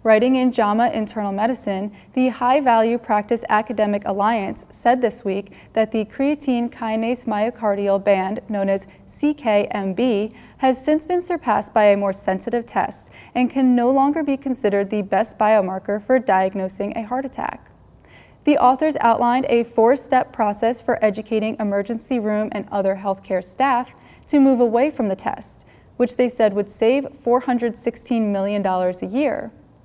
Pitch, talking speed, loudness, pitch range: 225 Hz, 155 wpm, -20 LUFS, 205-250 Hz